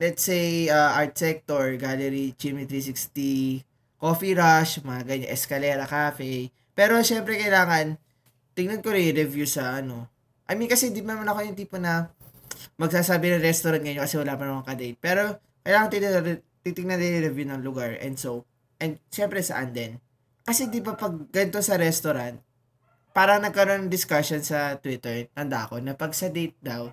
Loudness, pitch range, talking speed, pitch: -25 LUFS, 130-180 Hz, 175 wpm, 150 Hz